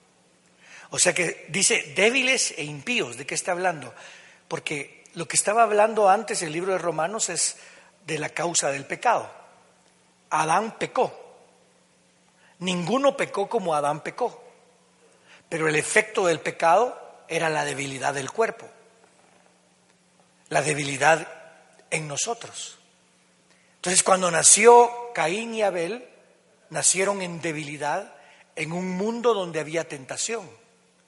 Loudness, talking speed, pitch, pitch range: -23 LUFS, 120 wpm, 170 Hz, 150-200 Hz